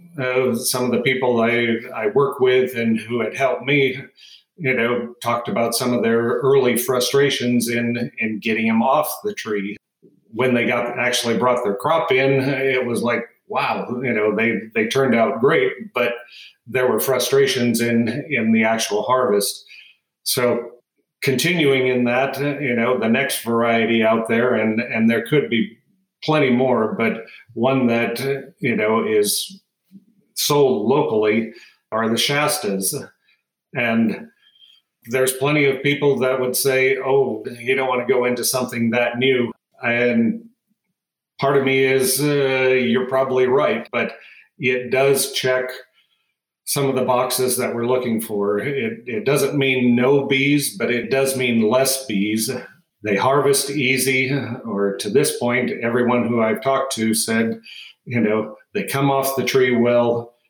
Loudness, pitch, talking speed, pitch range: -19 LUFS, 125 Hz, 160 wpm, 115-135 Hz